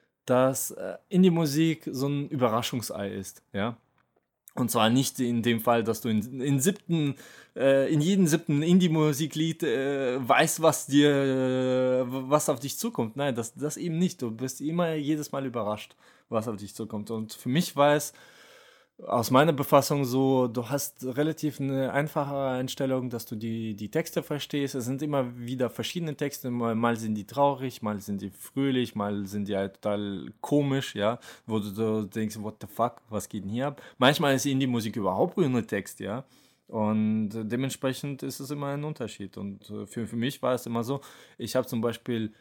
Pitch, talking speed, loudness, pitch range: 130 Hz, 185 wpm, -28 LUFS, 115-145 Hz